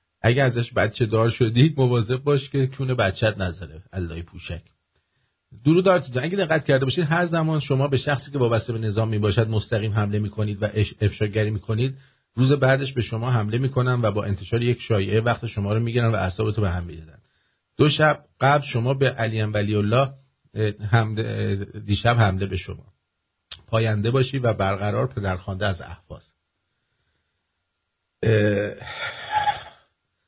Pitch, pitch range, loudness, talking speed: 110 Hz, 100-130 Hz, -22 LUFS, 155 wpm